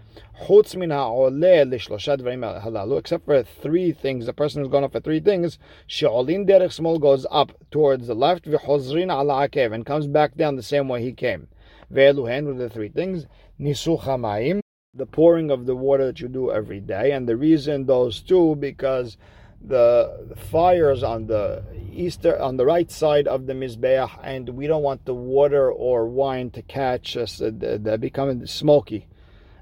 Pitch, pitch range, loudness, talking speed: 135 Hz, 120-150 Hz, -21 LUFS, 155 wpm